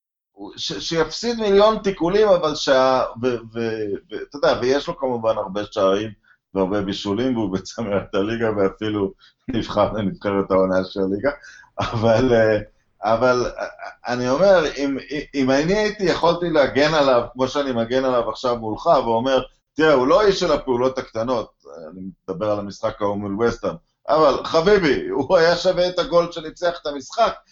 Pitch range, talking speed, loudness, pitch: 105-155 Hz, 140 wpm, -20 LUFS, 125 Hz